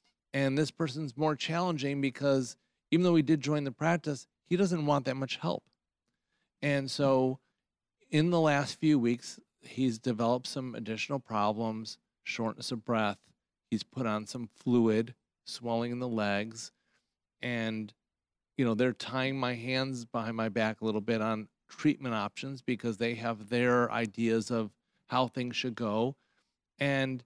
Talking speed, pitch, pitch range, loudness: 155 wpm, 125 Hz, 115-140 Hz, -32 LUFS